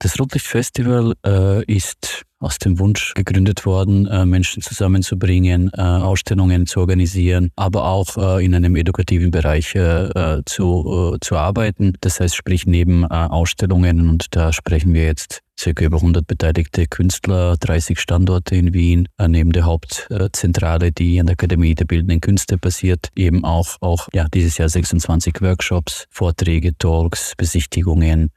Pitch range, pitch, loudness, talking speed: 85-95 Hz, 90 Hz, -17 LUFS, 155 wpm